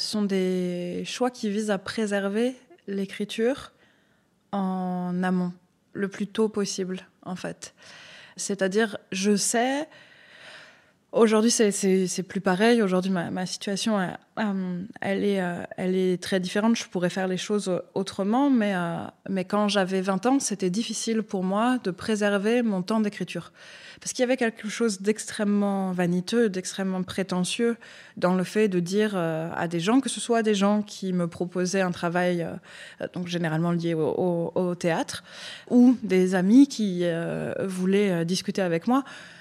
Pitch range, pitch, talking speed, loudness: 180-220 Hz, 195 Hz, 155 wpm, -25 LUFS